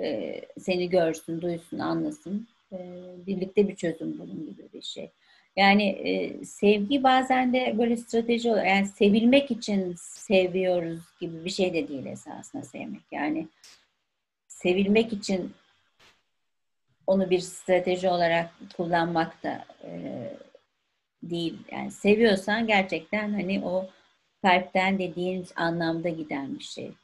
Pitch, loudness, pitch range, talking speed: 185 Hz, -26 LUFS, 175-210 Hz, 110 wpm